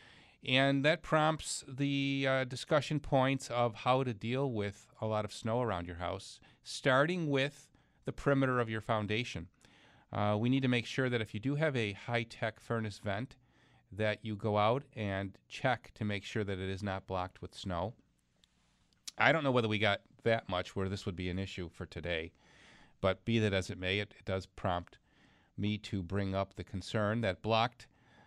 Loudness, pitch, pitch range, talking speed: -34 LUFS, 110 Hz, 100-130 Hz, 195 wpm